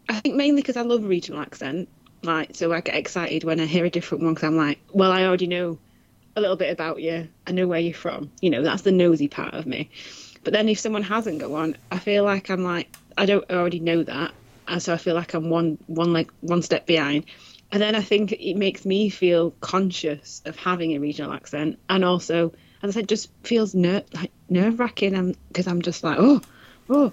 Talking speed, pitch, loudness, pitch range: 230 wpm, 180 Hz, -23 LUFS, 165-200 Hz